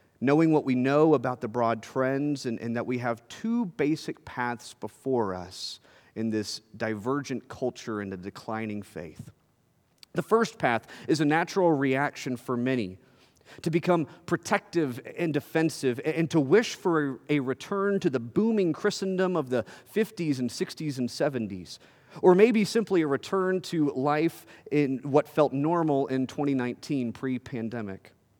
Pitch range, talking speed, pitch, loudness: 120-165 Hz, 150 wpm, 140 Hz, -28 LUFS